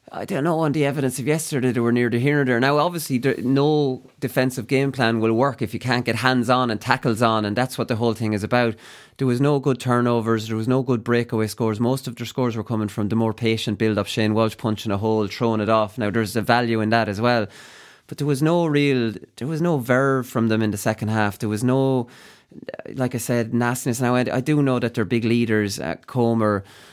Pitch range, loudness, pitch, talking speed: 110-130 Hz, -21 LUFS, 120 Hz, 250 wpm